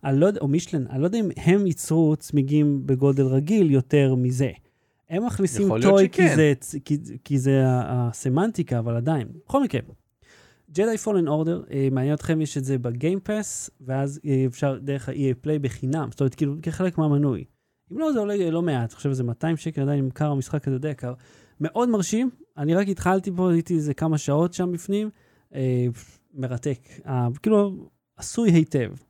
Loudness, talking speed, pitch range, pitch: -23 LUFS, 165 wpm, 130-175 Hz, 150 Hz